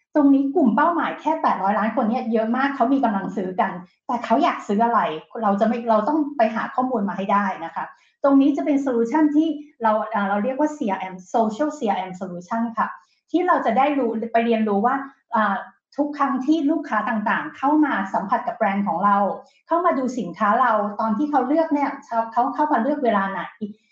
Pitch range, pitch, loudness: 215-285 Hz, 240 Hz, -21 LUFS